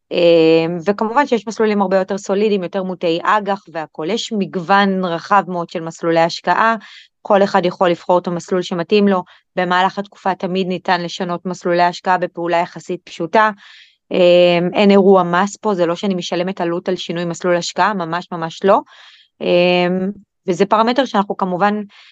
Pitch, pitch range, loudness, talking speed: 185 Hz, 175-200 Hz, -16 LUFS, 150 wpm